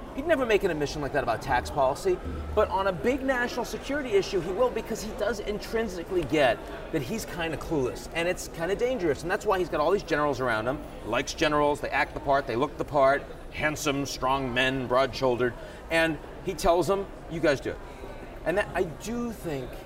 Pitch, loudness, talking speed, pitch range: 175 Hz, -28 LUFS, 215 wpm, 145-225 Hz